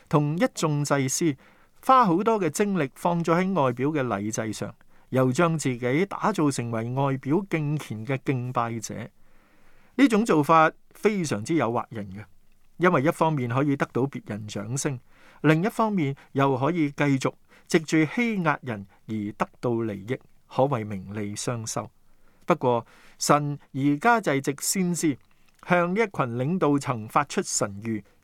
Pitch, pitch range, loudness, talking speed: 140 Hz, 115-165 Hz, -25 LUFS, 225 characters per minute